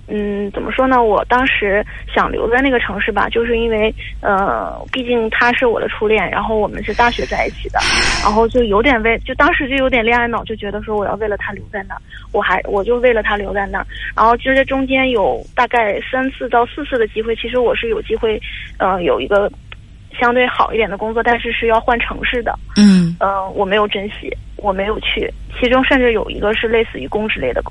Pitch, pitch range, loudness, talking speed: 230 Hz, 210-255 Hz, -15 LUFS, 325 characters per minute